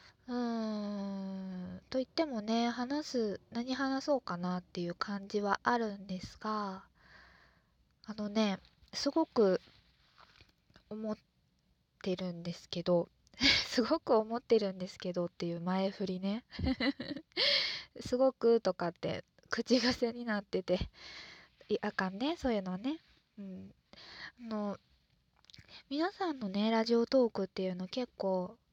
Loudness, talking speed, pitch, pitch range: -34 LUFS, 235 characters per minute, 215 Hz, 190-245 Hz